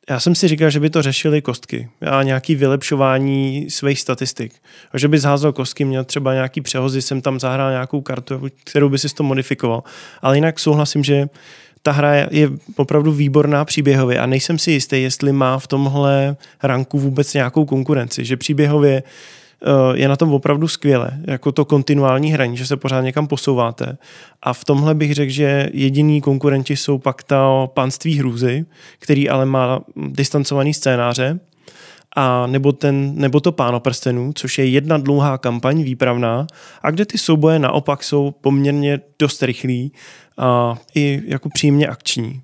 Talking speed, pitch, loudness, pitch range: 165 wpm, 140 Hz, -17 LUFS, 130-150 Hz